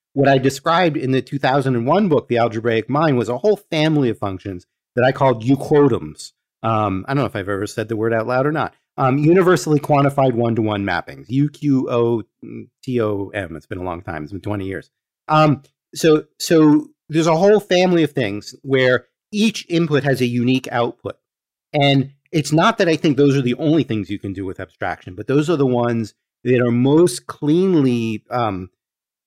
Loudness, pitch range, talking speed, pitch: -18 LUFS, 115-150 Hz, 195 wpm, 130 Hz